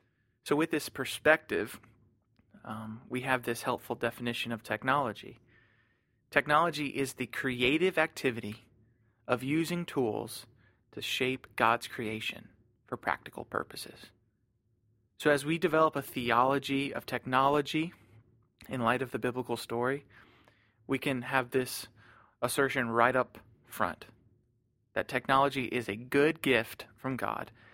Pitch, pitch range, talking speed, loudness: 120 Hz, 115-135 Hz, 125 wpm, -31 LUFS